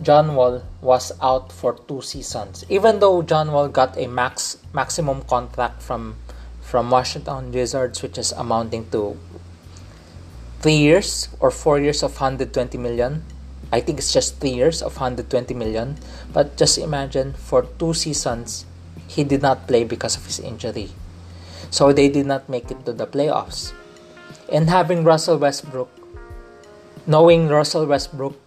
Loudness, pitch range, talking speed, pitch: -20 LUFS, 95-145 Hz, 150 wpm, 130 Hz